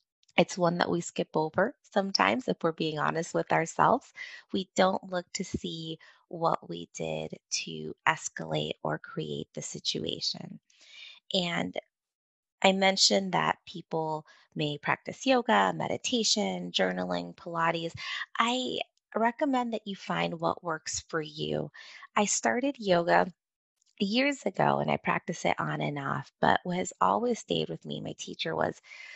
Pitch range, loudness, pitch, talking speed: 150-215 Hz, -30 LUFS, 180 Hz, 140 wpm